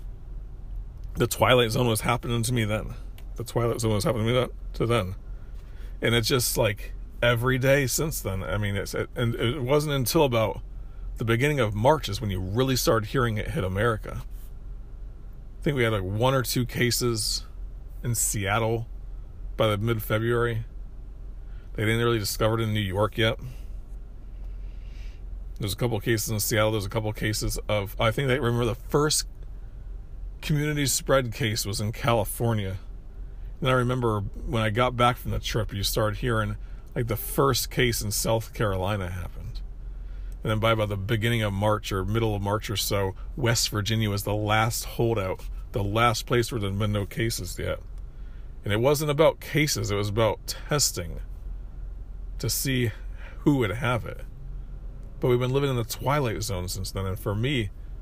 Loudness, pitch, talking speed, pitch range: -26 LUFS, 115 Hz, 180 wpm, 105-120 Hz